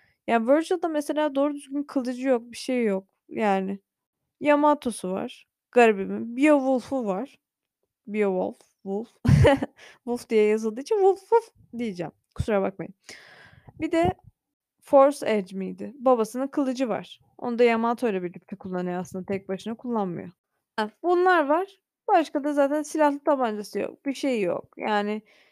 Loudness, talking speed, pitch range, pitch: -25 LUFS, 135 wpm, 205-290 Hz, 240 Hz